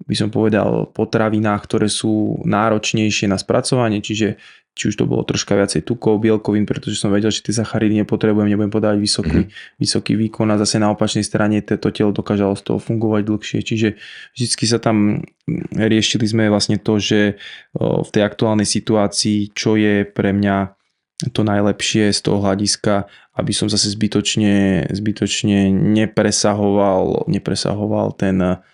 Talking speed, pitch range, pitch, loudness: 150 wpm, 100-110 Hz, 105 Hz, -17 LUFS